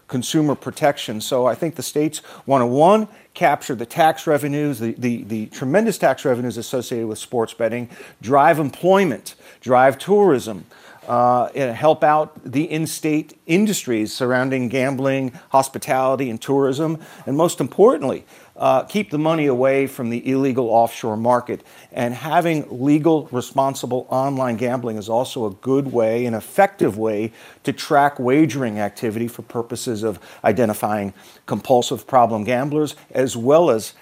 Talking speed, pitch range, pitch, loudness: 145 wpm, 120-150 Hz, 130 Hz, -19 LUFS